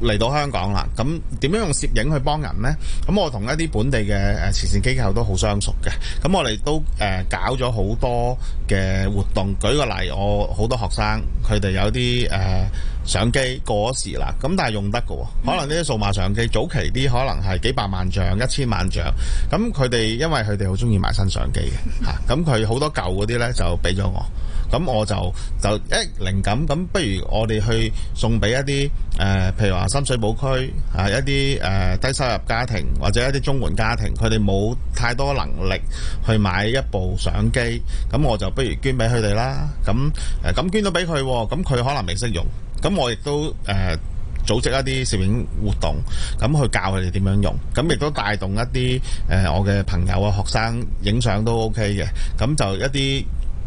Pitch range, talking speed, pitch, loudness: 95-130 Hz, 290 characters per minute, 110 Hz, -22 LUFS